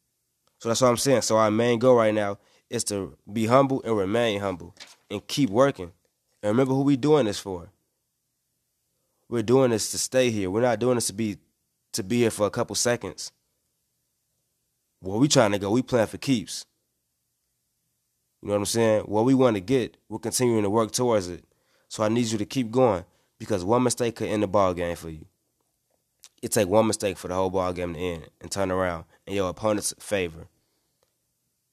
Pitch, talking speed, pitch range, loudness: 110 Hz, 200 wpm, 95-120 Hz, -24 LUFS